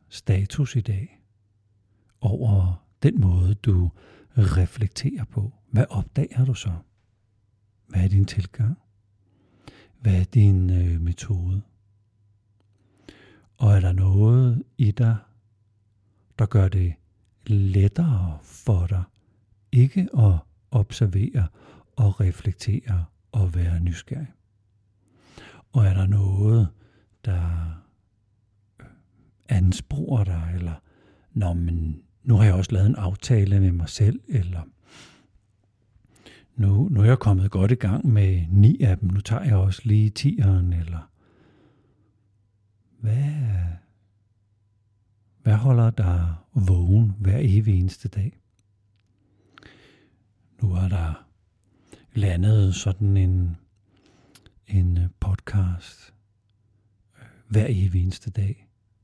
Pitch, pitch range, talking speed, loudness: 105 Hz, 95-110 Hz, 105 wpm, -22 LUFS